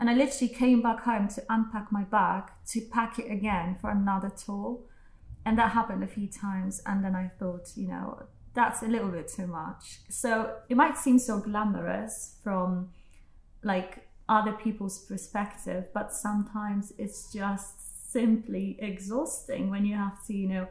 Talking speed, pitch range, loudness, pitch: 170 wpm, 195-230 Hz, -30 LUFS, 205 Hz